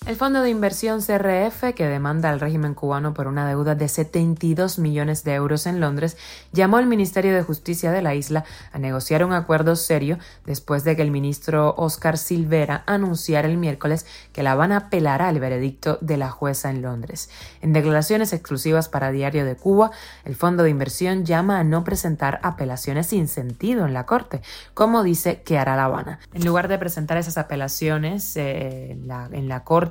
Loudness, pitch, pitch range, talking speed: -21 LUFS, 160 Hz, 145-175 Hz, 185 wpm